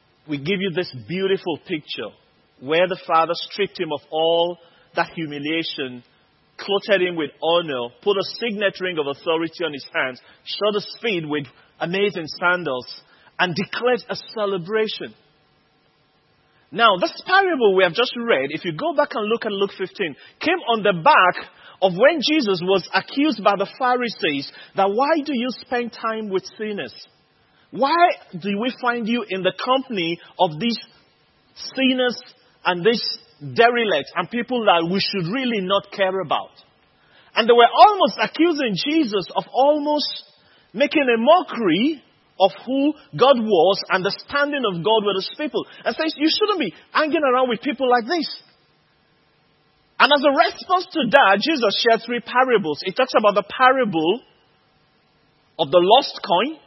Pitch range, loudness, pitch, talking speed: 180-260 Hz, -20 LUFS, 210 Hz, 160 wpm